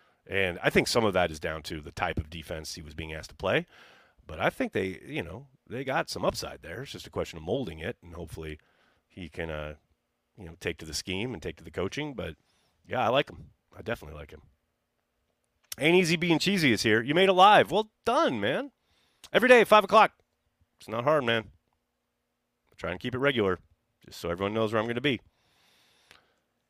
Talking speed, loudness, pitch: 220 wpm, -27 LUFS, 105 Hz